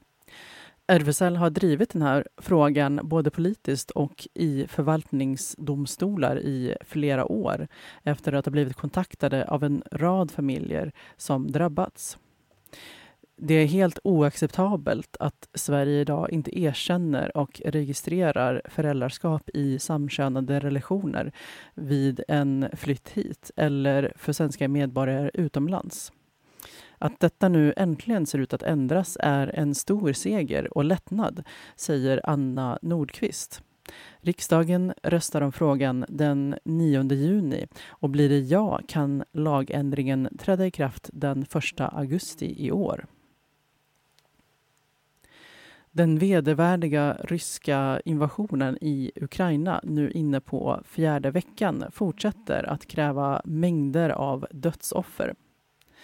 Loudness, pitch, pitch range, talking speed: -26 LUFS, 150 Hz, 140-170 Hz, 110 wpm